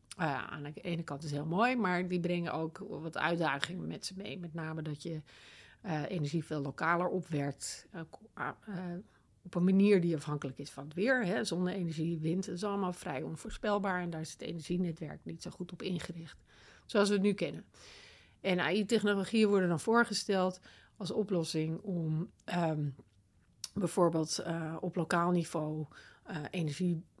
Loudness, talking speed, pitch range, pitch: -34 LUFS, 170 wpm, 160-185 Hz, 175 Hz